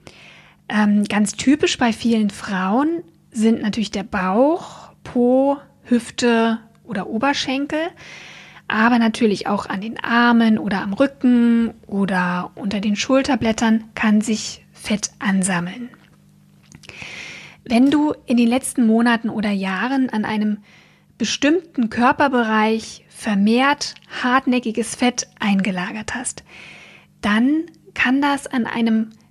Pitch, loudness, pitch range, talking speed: 230 Hz, -19 LUFS, 210-255 Hz, 105 wpm